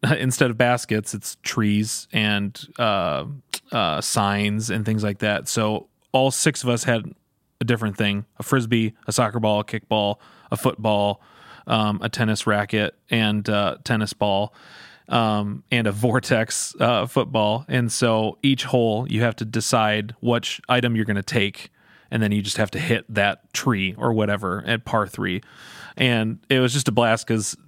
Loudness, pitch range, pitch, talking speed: -22 LUFS, 105-120 Hz, 110 Hz, 175 wpm